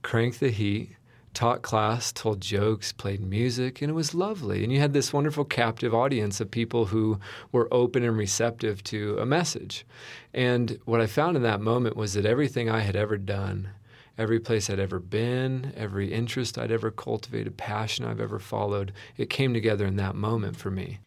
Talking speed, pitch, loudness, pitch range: 190 wpm, 115 Hz, -27 LUFS, 105-125 Hz